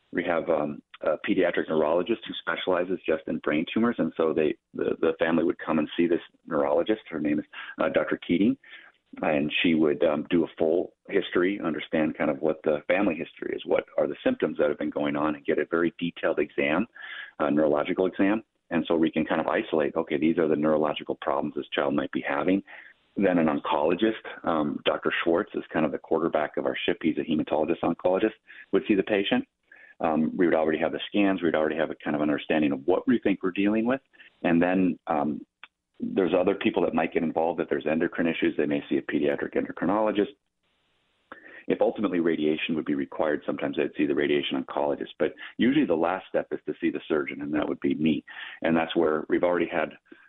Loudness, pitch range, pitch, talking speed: -26 LUFS, 80-135 Hz, 95 Hz, 210 wpm